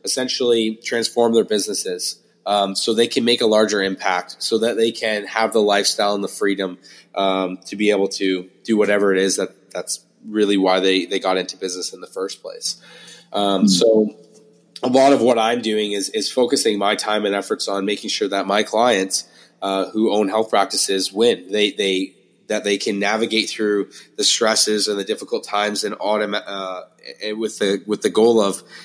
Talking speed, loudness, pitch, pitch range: 195 wpm, -19 LUFS, 105 Hz, 100-110 Hz